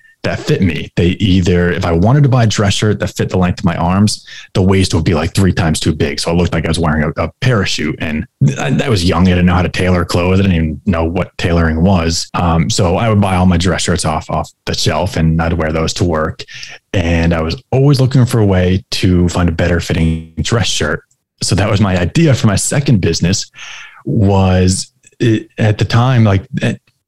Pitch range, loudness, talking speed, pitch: 85-105 Hz, -13 LUFS, 240 wpm, 90 Hz